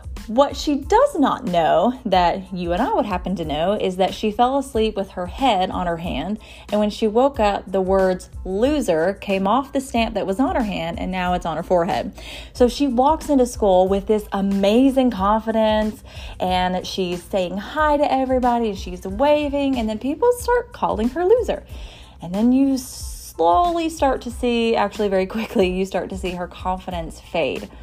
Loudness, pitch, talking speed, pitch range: -20 LUFS, 215 Hz, 190 wpm, 185-265 Hz